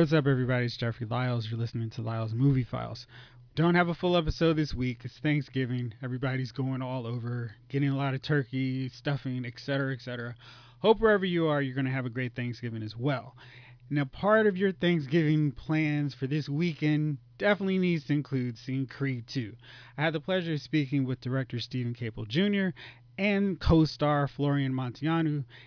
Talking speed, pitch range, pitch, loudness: 180 wpm, 125-155 Hz, 135 Hz, -29 LUFS